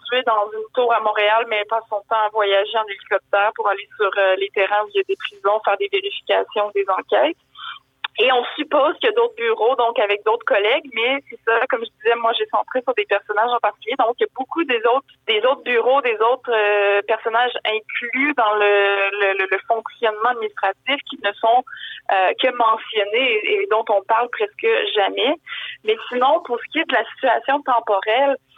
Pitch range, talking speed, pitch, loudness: 210-275 Hz, 200 wpm, 230 Hz, -19 LUFS